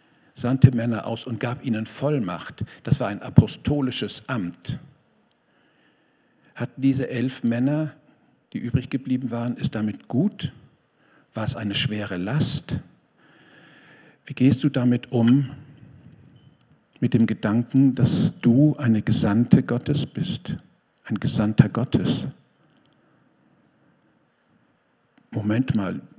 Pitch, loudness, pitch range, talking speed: 125 Hz, -23 LUFS, 115-135 Hz, 110 wpm